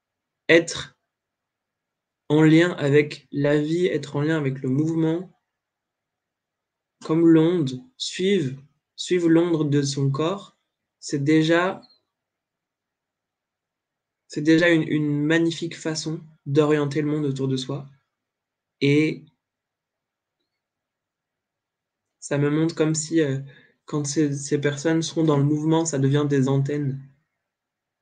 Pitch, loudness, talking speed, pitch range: 150 Hz, -22 LUFS, 115 wpm, 145-160 Hz